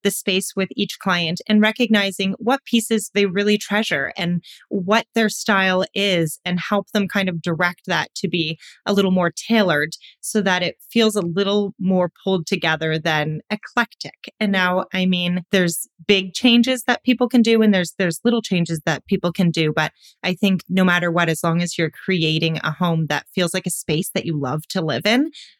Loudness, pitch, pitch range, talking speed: -20 LUFS, 190 Hz, 170-210 Hz, 200 wpm